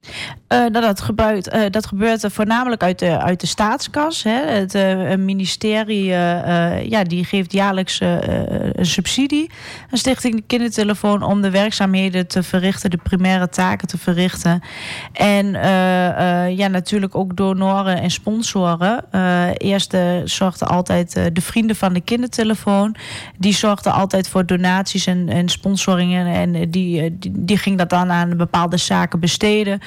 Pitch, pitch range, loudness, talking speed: 190 Hz, 180-210 Hz, -17 LUFS, 160 wpm